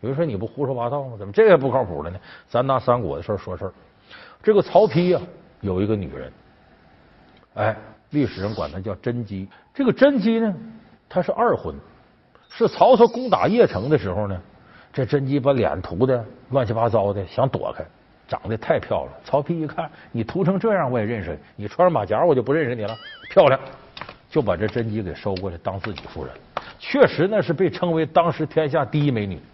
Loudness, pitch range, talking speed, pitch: -21 LUFS, 105-170 Hz, 295 characters per minute, 125 Hz